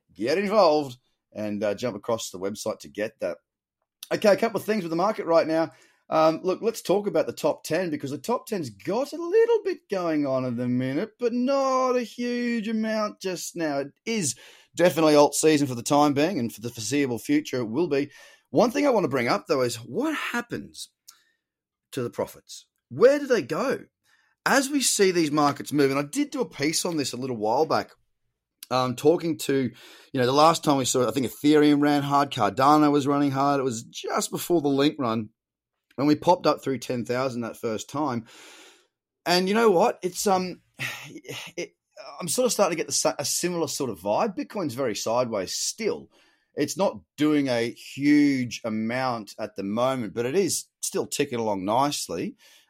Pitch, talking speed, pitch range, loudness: 150 Hz, 200 wpm, 130-200 Hz, -25 LUFS